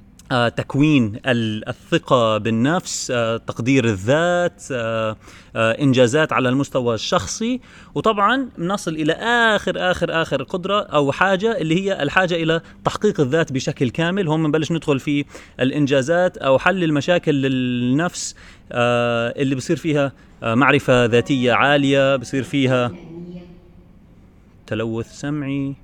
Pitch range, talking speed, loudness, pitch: 120-170 Hz, 105 wpm, -19 LUFS, 140 Hz